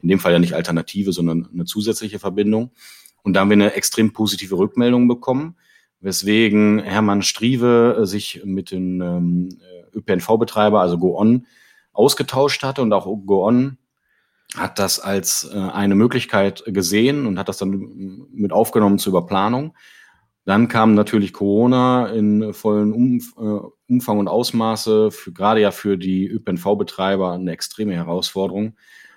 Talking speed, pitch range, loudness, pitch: 140 wpm, 95-110 Hz, -18 LUFS, 105 Hz